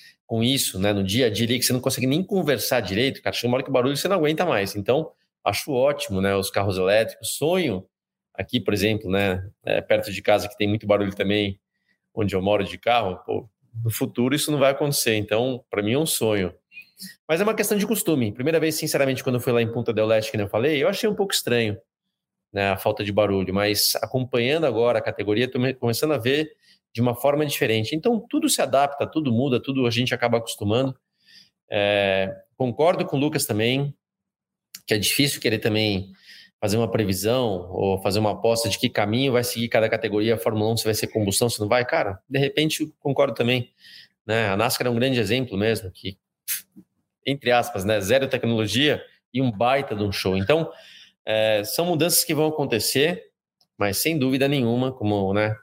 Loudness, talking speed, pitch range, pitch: -22 LUFS, 205 wpm, 105-140 Hz, 120 Hz